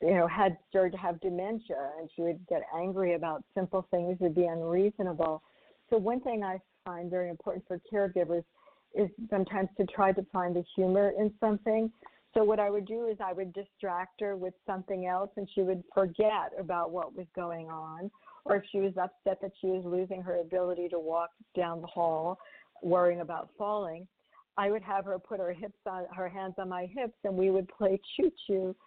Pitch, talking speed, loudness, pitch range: 190 Hz, 205 wpm, -32 LUFS, 180-200 Hz